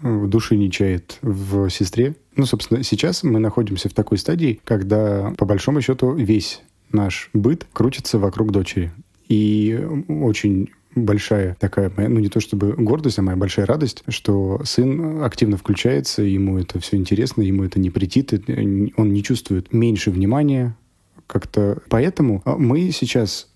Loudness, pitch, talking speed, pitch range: -19 LUFS, 105 Hz, 150 wpm, 100-125 Hz